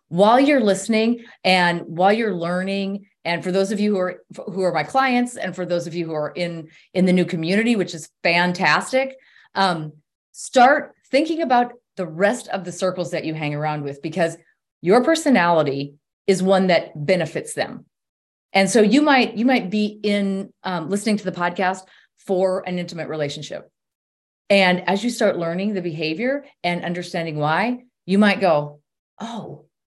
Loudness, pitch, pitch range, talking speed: -20 LUFS, 185 Hz, 170-210 Hz, 175 wpm